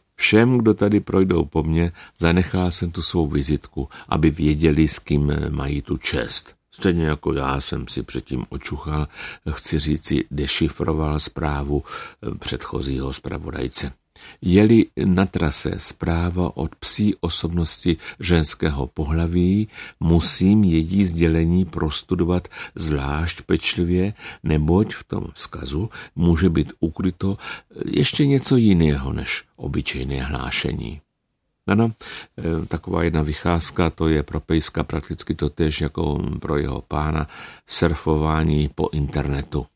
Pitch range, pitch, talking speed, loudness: 75-90 Hz, 80 Hz, 115 wpm, -21 LUFS